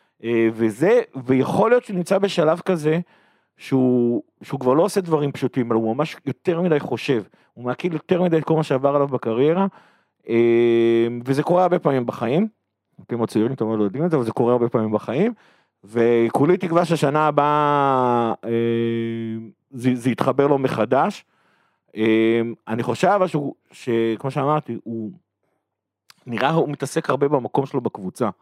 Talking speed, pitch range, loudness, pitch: 150 wpm, 115-155 Hz, -20 LUFS, 130 Hz